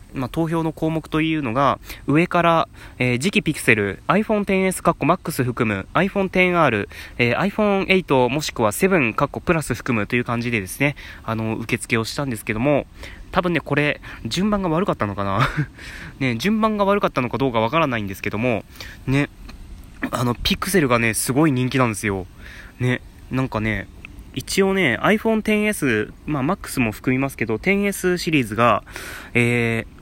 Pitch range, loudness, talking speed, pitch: 110-165 Hz, -20 LUFS, 355 characters per minute, 130 Hz